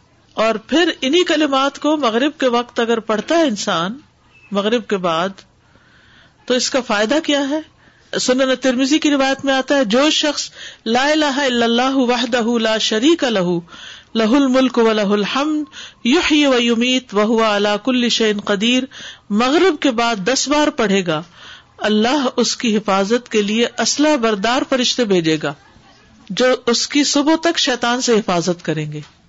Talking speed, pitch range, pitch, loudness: 160 wpm, 215-280 Hz, 245 Hz, -16 LUFS